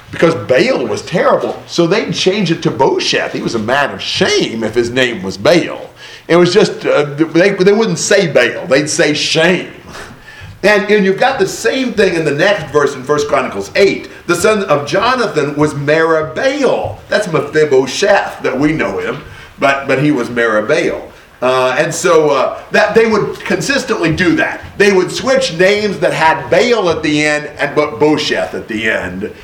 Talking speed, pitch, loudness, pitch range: 185 wpm, 160 Hz, -12 LUFS, 145-200 Hz